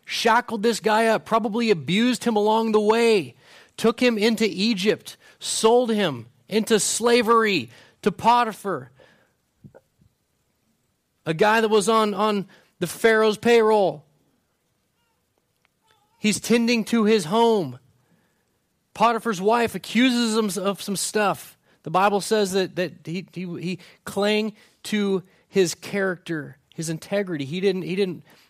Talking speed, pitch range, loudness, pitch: 125 wpm, 180-225 Hz, -22 LUFS, 210 Hz